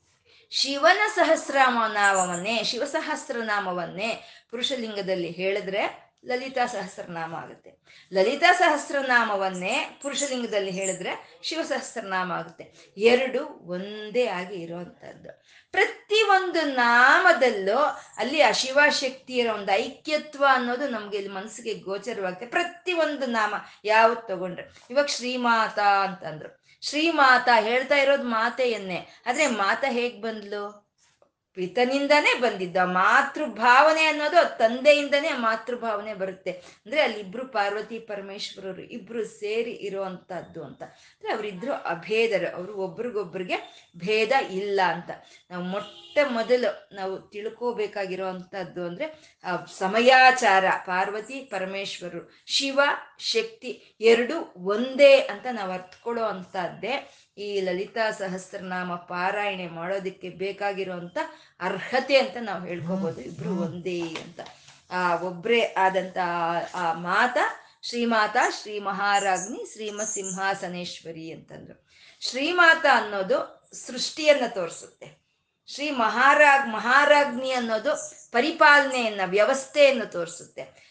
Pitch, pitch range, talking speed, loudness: 220 Hz, 190-270 Hz, 90 wpm, -24 LUFS